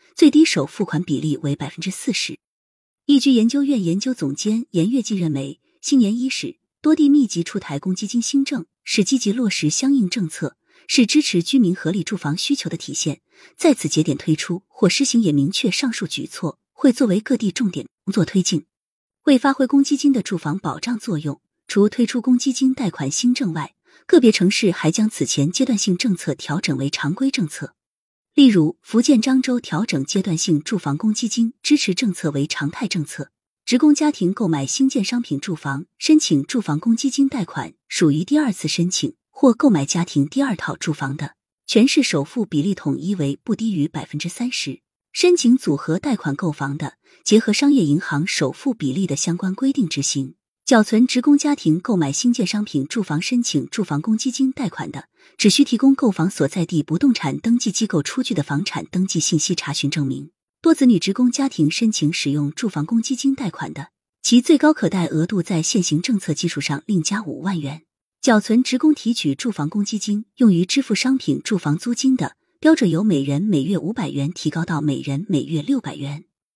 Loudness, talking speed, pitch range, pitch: -19 LUFS, 295 characters per minute, 155-250 Hz, 200 Hz